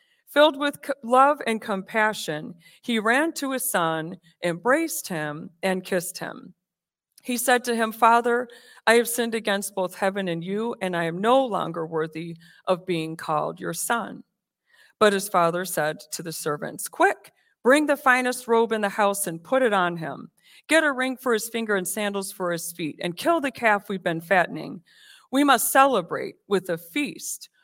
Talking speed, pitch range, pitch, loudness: 180 wpm, 175-250 Hz, 205 Hz, -24 LUFS